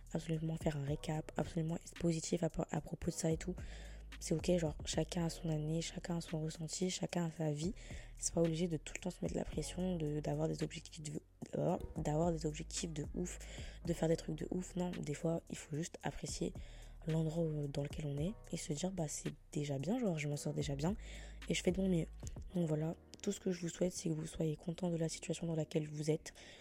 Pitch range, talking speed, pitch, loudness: 155-175 Hz, 245 wpm, 165 Hz, -40 LUFS